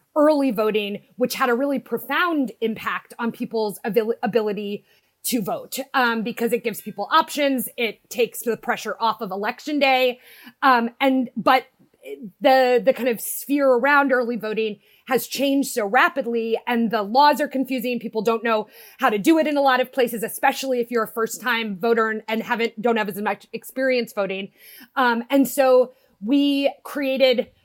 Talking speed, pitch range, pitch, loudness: 175 wpm, 225-265 Hz, 245 Hz, -21 LUFS